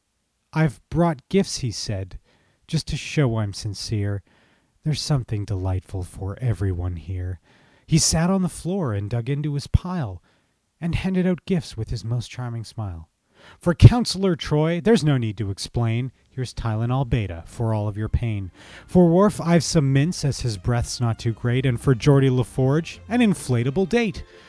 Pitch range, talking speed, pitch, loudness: 105-155 Hz, 170 wpm, 125 Hz, -23 LUFS